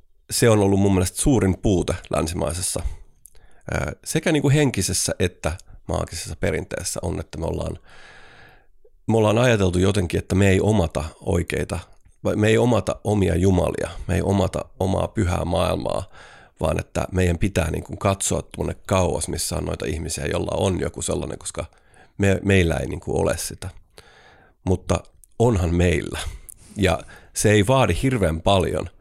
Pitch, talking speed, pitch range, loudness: 95 Hz, 150 wpm, 85-100 Hz, -22 LUFS